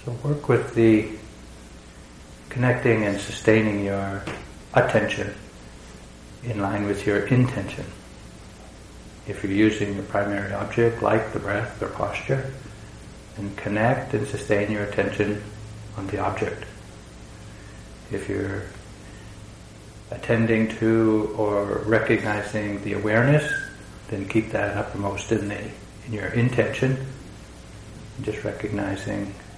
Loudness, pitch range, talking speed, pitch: -24 LUFS, 100-110 Hz, 110 wpm, 105 Hz